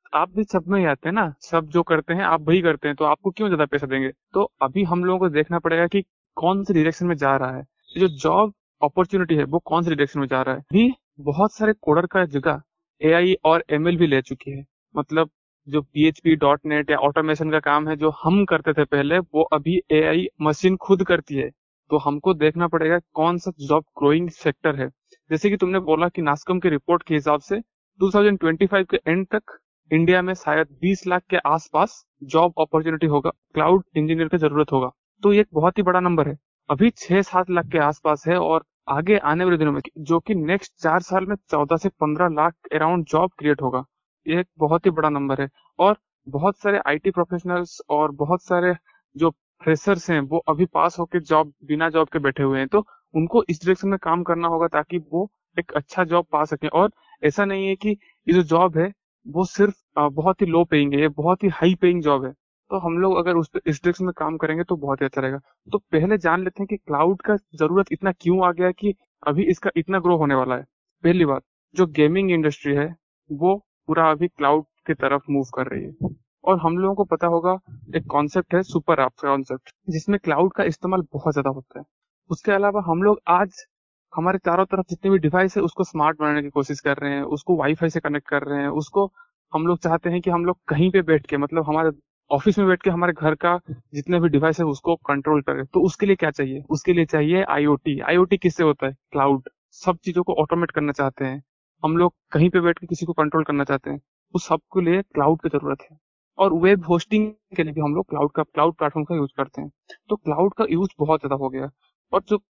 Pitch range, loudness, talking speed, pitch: 150-185 Hz, -21 LUFS, 205 wpm, 165 Hz